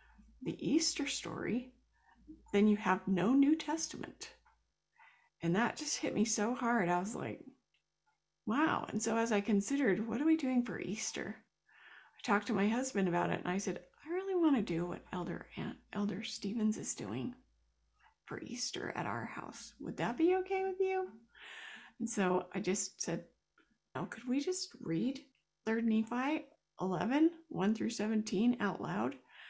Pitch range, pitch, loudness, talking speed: 200-290 Hz, 225 Hz, -35 LUFS, 165 wpm